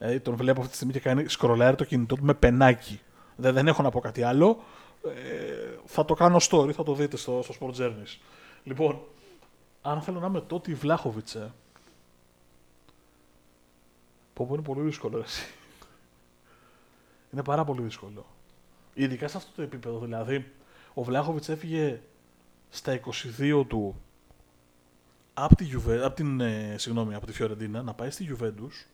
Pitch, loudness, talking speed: 125 Hz, -27 LUFS, 150 wpm